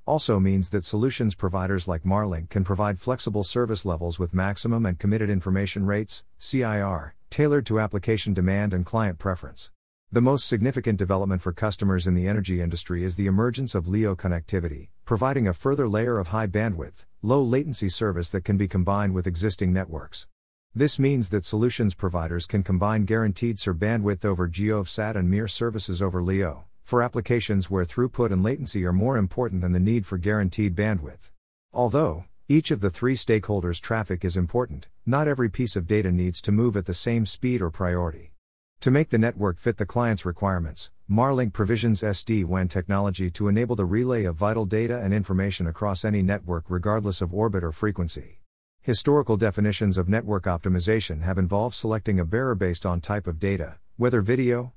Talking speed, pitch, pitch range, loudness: 175 wpm, 100 Hz, 90-115 Hz, -25 LUFS